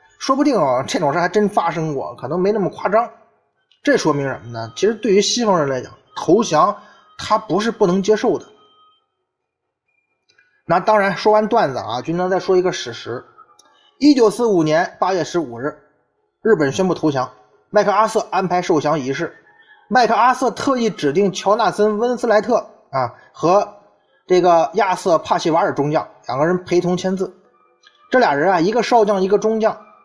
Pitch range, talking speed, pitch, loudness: 175-230 Hz, 265 characters per minute, 205 Hz, -17 LUFS